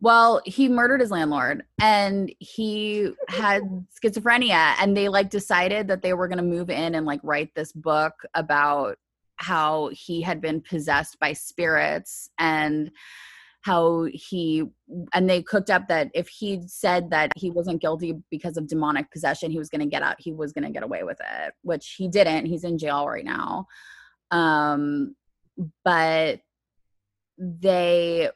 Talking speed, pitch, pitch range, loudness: 165 wpm, 170 Hz, 155-190 Hz, -23 LUFS